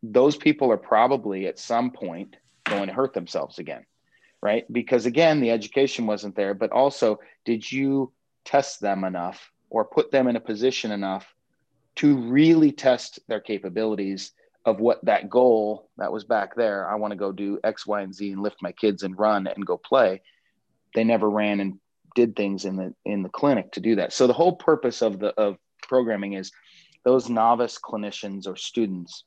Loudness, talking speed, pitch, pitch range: -24 LUFS, 190 wpm, 110 Hz, 100-130 Hz